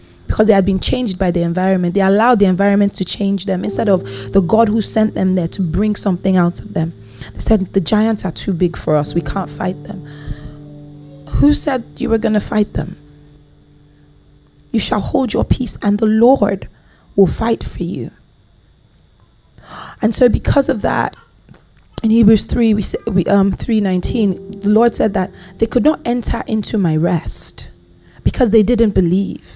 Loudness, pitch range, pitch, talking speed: -16 LUFS, 170-220 Hz, 195 Hz, 185 wpm